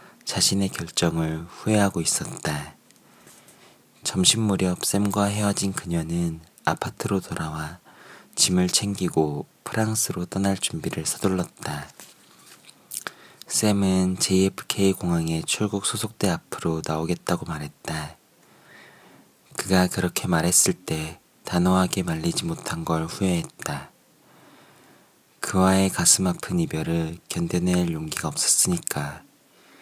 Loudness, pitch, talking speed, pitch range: -24 LUFS, 90 Hz, 235 characters per minute, 80-100 Hz